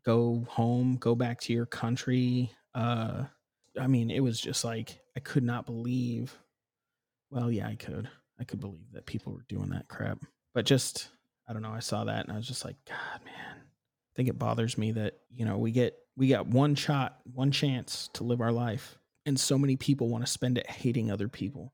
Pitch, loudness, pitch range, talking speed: 120 Hz, -31 LUFS, 115-130 Hz, 215 wpm